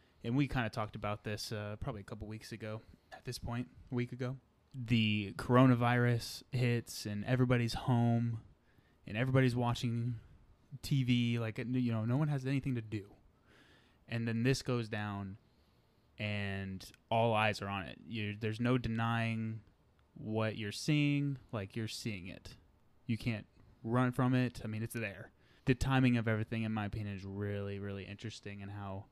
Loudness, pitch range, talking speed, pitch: -36 LUFS, 105-125 Hz, 170 wpm, 115 Hz